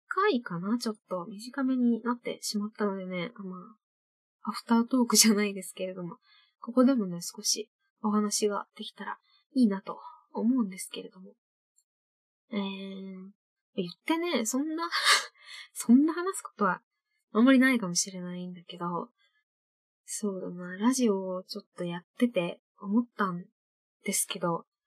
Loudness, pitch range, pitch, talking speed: -29 LUFS, 190-245 Hz, 215 Hz, 300 characters per minute